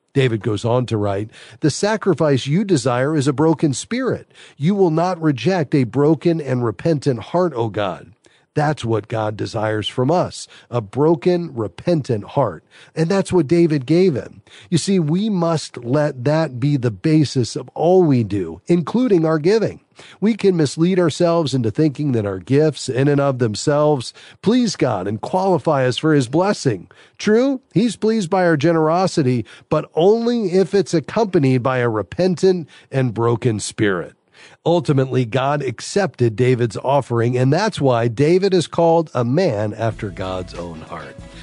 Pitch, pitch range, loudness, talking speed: 150 Hz, 120-175 Hz, -18 LUFS, 160 wpm